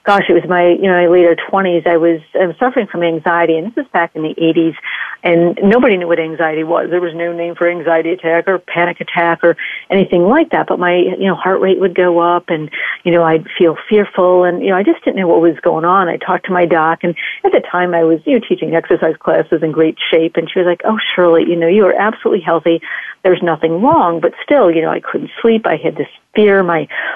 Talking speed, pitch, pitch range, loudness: 255 wpm, 175 Hz, 165-185 Hz, -13 LUFS